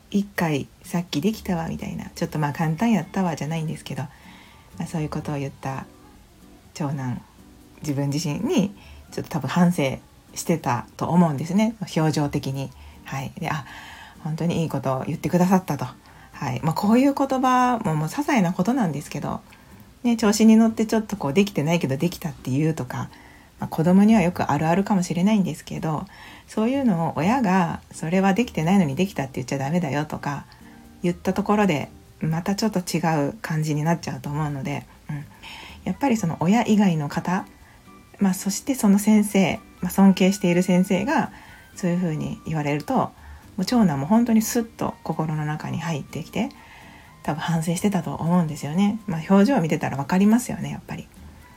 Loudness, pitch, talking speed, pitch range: -23 LUFS, 170 Hz, 385 characters per minute, 150-200 Hz